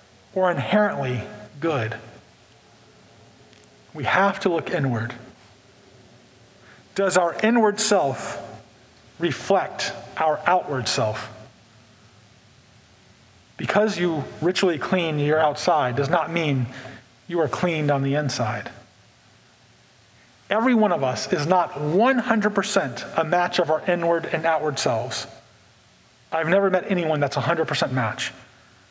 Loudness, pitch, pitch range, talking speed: -22 LUFS, 145 Hz, 115-175 Hz, 110 wpm